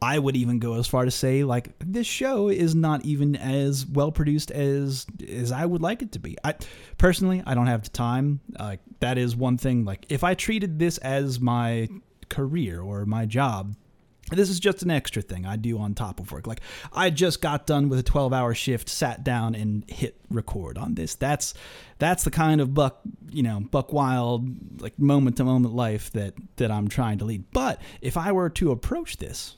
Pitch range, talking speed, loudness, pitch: 115-155 Hz, 215 wpm, -25 LUFS, 130 Hz